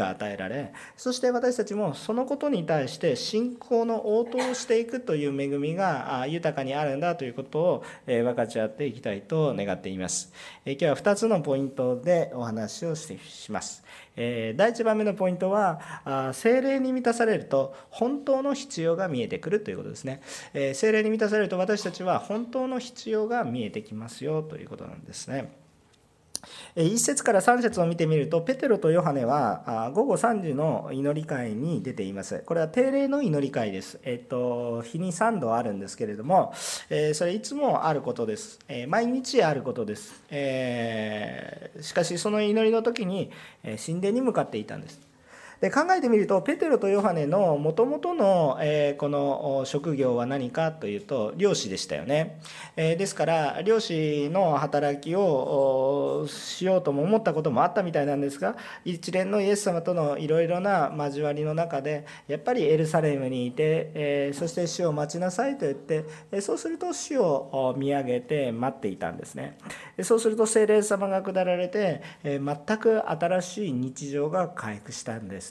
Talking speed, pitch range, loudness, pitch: 330 characters per minute, 140-220 Hz, -27 LUFS, 165 Hz